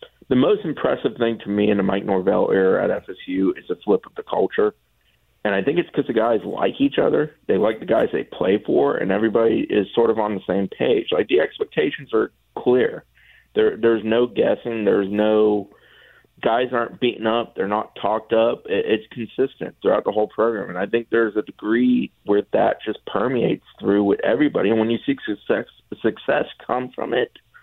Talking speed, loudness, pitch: 200 wpm, -21 LUFS, 115 Hz